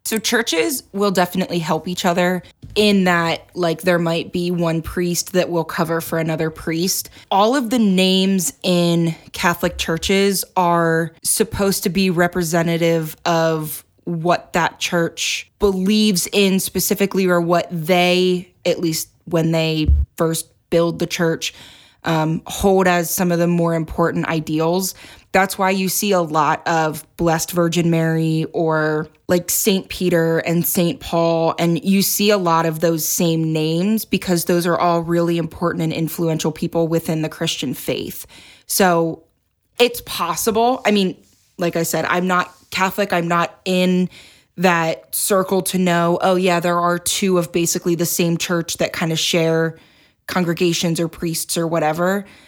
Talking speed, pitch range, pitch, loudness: 155 wpm, 165-185 Hz, 170 Hz, -18 LUFS